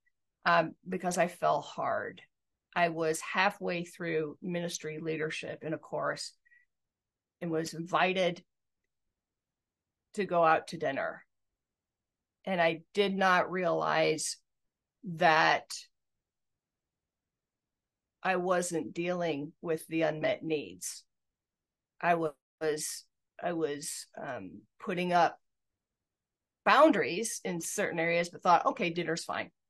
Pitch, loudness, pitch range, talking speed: 170 Hz, -31 LUFS, 160-180 Hz, 105 wpm